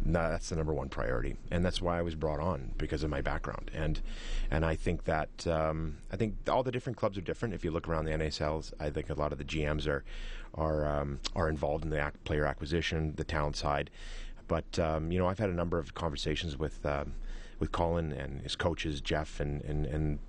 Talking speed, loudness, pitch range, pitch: 230 wpm, -34 LUFS, 75-85 Hz, 80 Hz